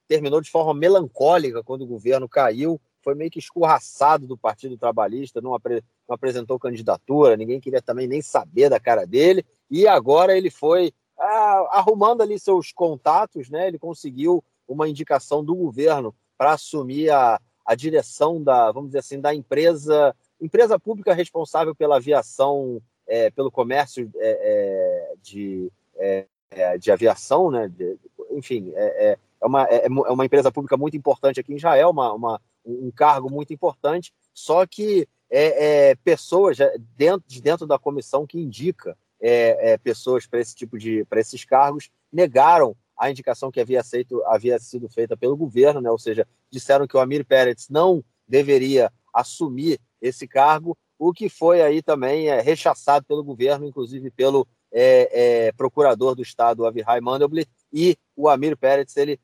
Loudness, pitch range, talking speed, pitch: -20 LUFS, 130-185 Hz, 165 wpm, 150 Hz